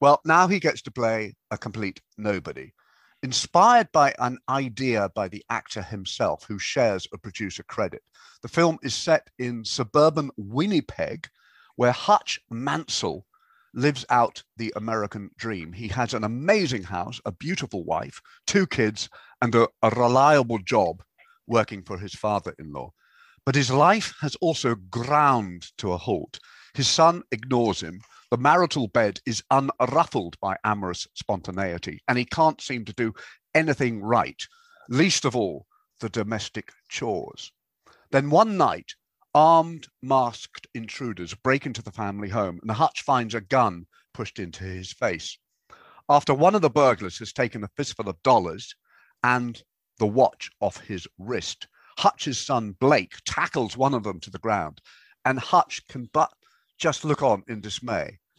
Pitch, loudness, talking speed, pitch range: 120 Hz, -24 LUFS, 155 wpm, 105-145 Hz